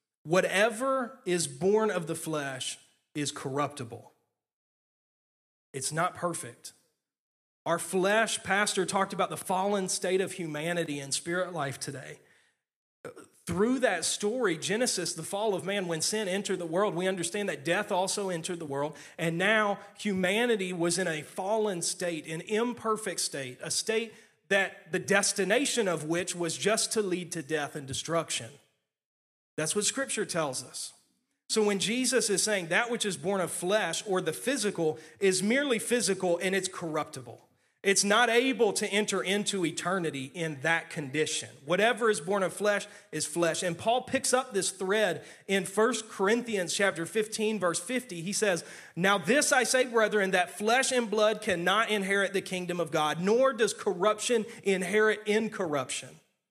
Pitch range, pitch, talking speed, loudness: 165-215 Hz, 190 Hz, 160 wpm, -29 LUFS